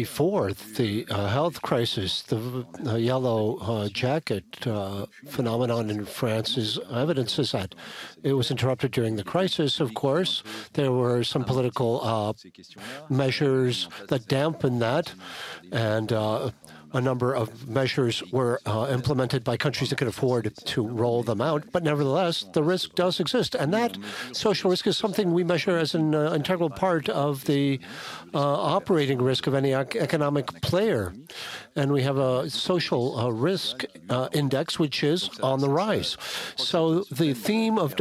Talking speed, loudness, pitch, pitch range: 155 wpm, -26 LUFS, 135 Hz, 120-155 Hz